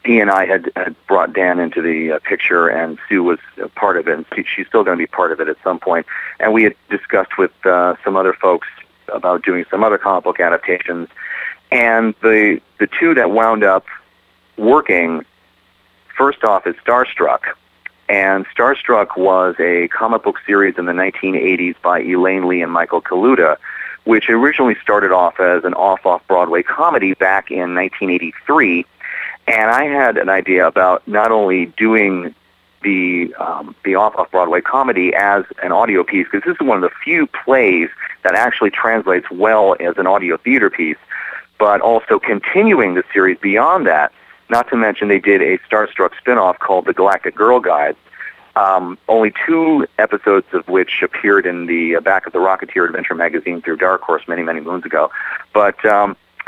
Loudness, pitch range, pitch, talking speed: -14 LUFS, 90-105 Hz, 95 Hz, 175 wpm